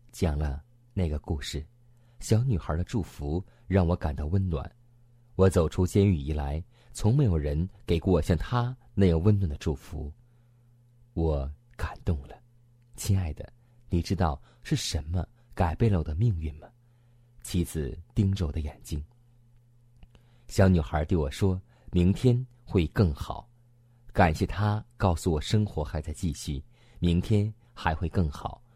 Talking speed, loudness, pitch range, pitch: 205 characters per minute, -28 LUFS, 80-120 Hz, 95 Hz